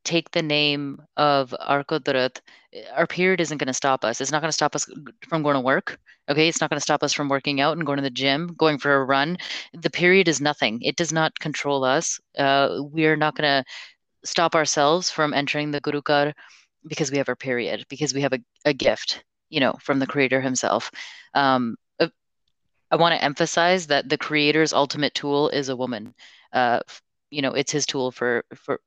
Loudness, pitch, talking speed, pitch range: -22 LUFS, 145 Hz, 210 wpm, 140-155 Hz